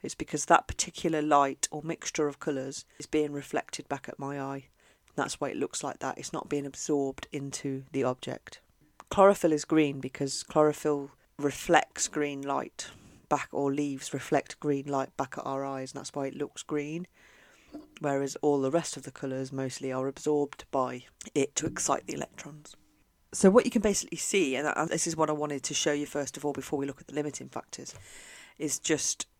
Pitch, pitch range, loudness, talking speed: 145 Hz, 135-150 Hz, -30 LUFS, 200 wpm